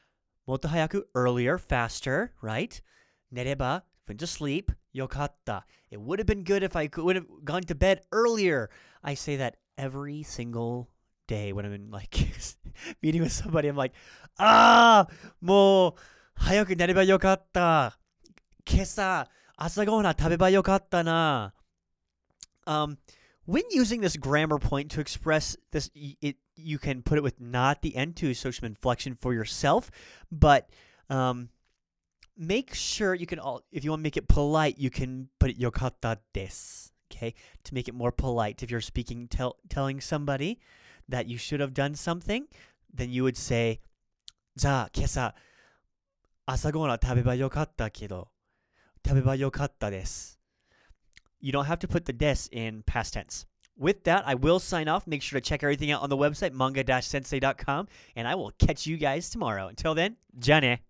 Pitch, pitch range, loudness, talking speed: 140 Hz, 120-165 Hz, -27 LUFS, 155 wpm